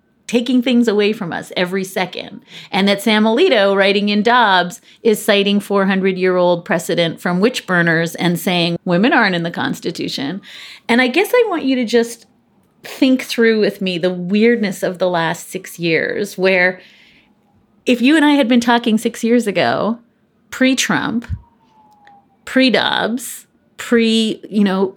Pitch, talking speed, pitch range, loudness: 215 Hz, 160 wpm, 185-235 Hz, -15 LUFS